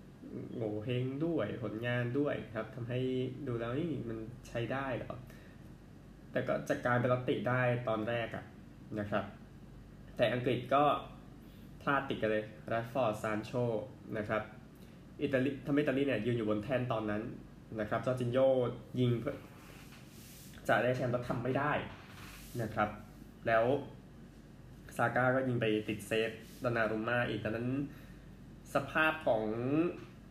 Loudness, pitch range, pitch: -35 LUFS, 110-130 Hz, 120 Hz